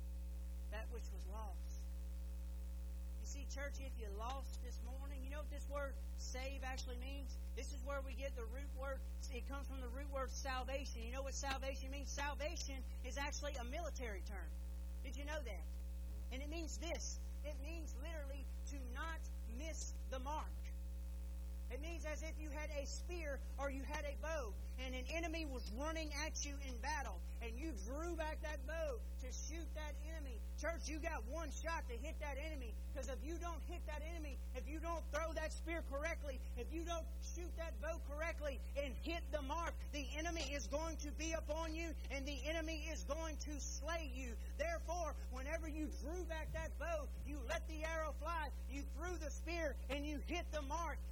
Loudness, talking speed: -47 LUFS, 195 wpm